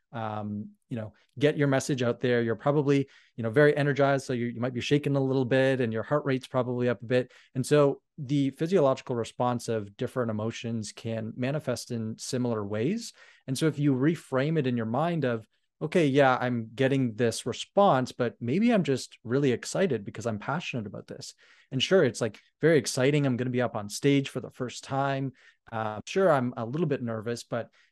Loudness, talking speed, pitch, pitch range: -28 LUFS, 210 wpm, 130 Hz, 115-140 Hz